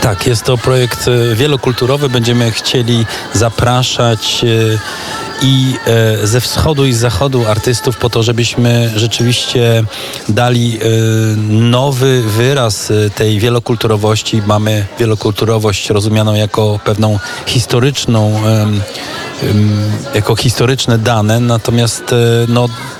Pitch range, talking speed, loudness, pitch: 110-125 Hz, 90 wpm, -12 LUFS, 115 Hz